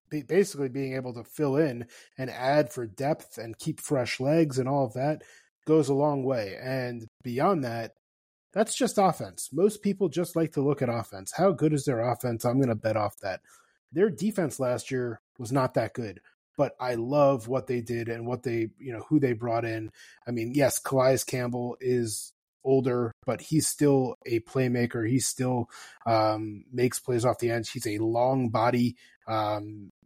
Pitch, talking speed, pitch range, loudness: 125 Hz, 190 wpm, 115-145 Hz, -28 LUFS